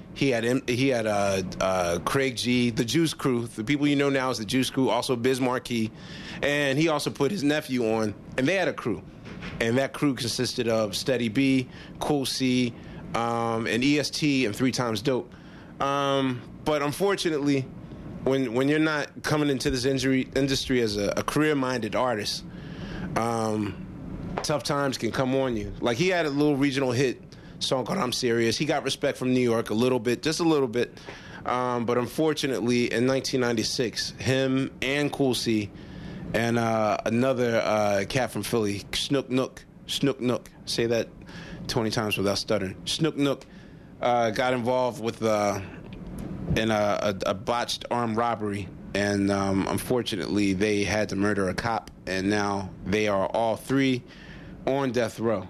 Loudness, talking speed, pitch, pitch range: -26 LUFS, 170 wpm, 125 Hz, 110-135 Hz